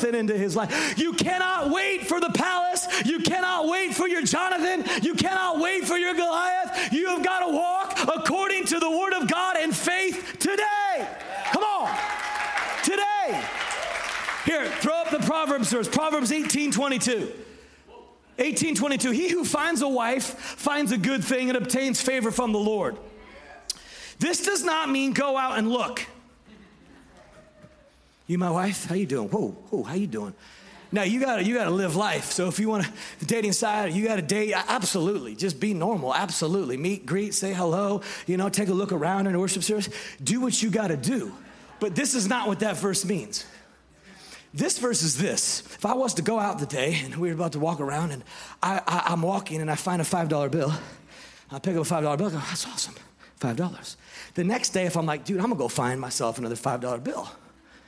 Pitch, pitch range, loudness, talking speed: 225 Hz, 190-315 Hz, -25 LUFS, 200 wpm